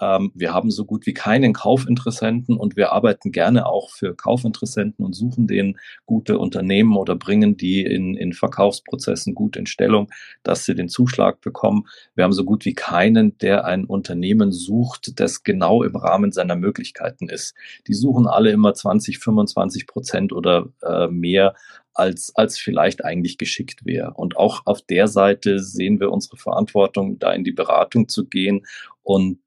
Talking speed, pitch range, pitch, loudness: 165 wpm, 95-130 Hz, 110 Hz, -19 LUFS